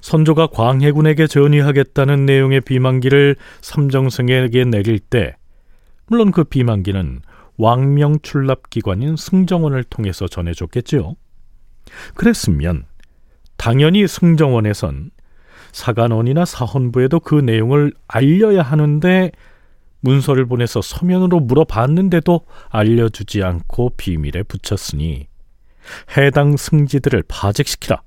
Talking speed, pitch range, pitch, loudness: 275 characters per minute, 105-150 Hz, 130 Hz, -15 LUFS